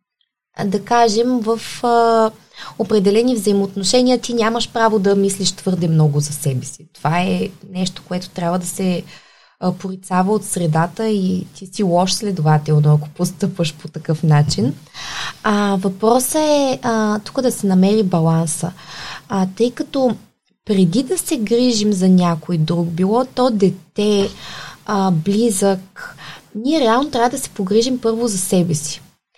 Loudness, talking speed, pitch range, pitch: -17 LUFS, 145 wpm, 175-230 Hz, 200 Hz